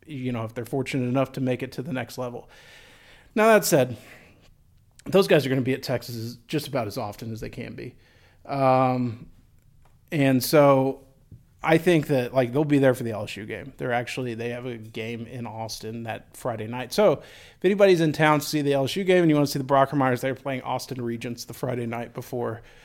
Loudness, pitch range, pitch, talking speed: -24 LUFS, 120-140 Hz, 130 Hz, 215 wpm